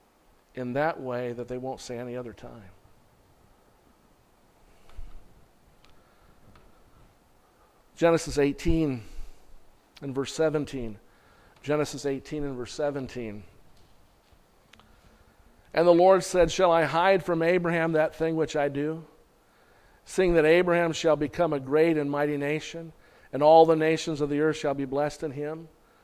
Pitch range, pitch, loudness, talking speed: 125-160 Hz, 145 Hz, -25 LUFS, 130 wpm